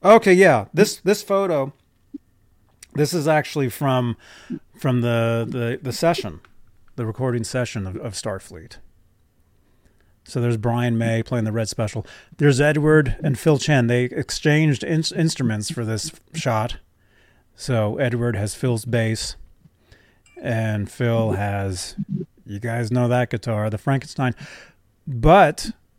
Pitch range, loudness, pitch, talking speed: 110-145 Hz, -21 LUFS, 120 Hz, 130 wpm